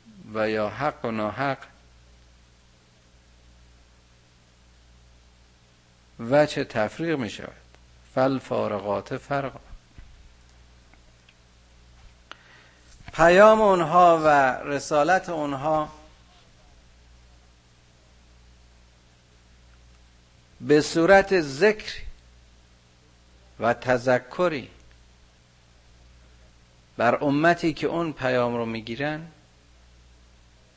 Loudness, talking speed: -23 LUFS, 60 wpm